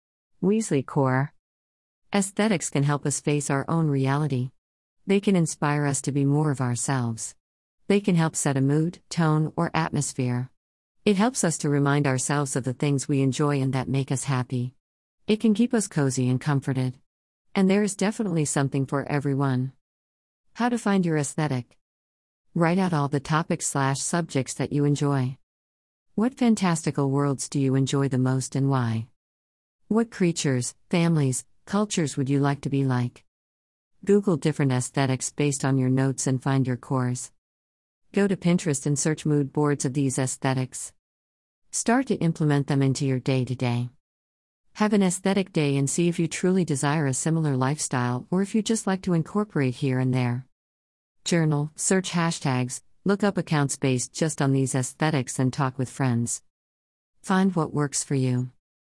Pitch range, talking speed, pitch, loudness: 125-160 Hz, 170 wpm, 140 Hz, -25 LUFS